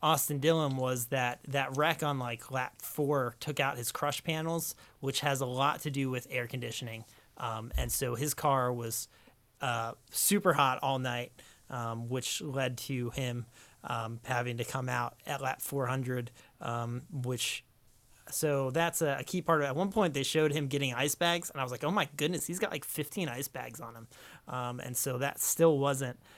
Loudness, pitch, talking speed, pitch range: -33 LUFS, 135 Hz, 200 wpm, 120-150 Hz